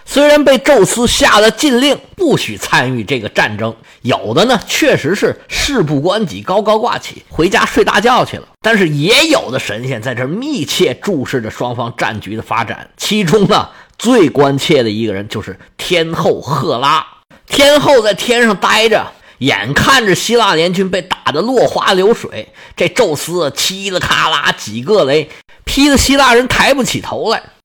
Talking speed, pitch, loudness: 250 characters per minute, 195 Hz, -12 LUFS